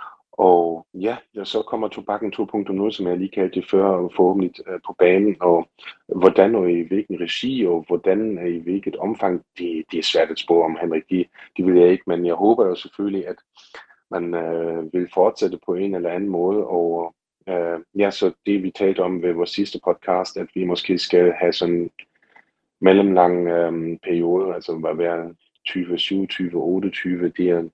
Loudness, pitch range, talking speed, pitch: -20 LUFS, 85-95 Hz, 185 wpm, 90 Hz